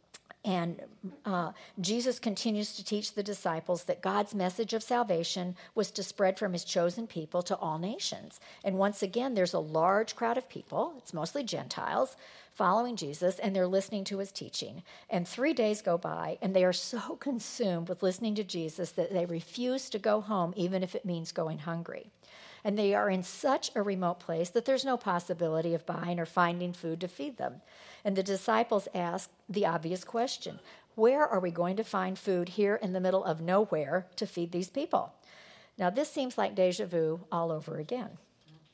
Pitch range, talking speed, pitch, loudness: 175-220 Hz, 190 wpm, 190 Hz, -32 LUFS